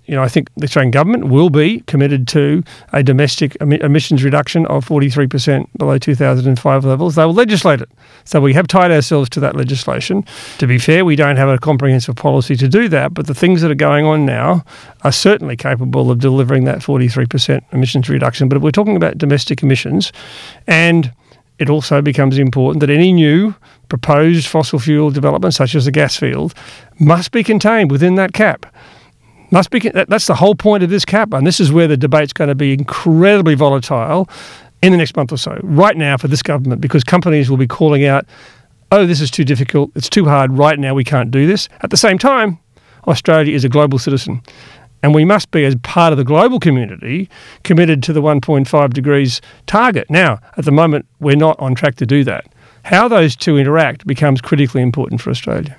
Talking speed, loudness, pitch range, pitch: 200 wpm, -12 LUFS, 135-165 Hz, 145 Hz